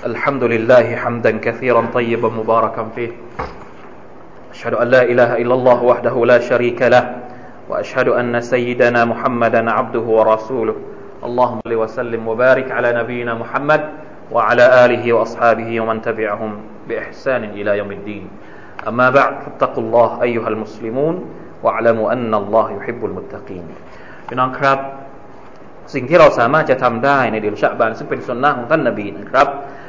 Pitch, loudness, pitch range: 120 Hz, -15 LUFS, 115-125 Hz